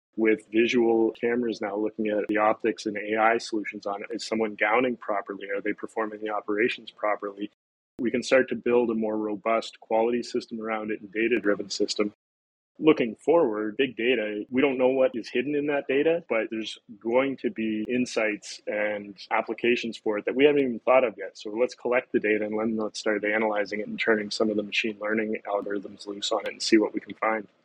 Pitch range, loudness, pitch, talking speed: 105-120 Hz, -26 LUFS, 110 Hz, 210 wpm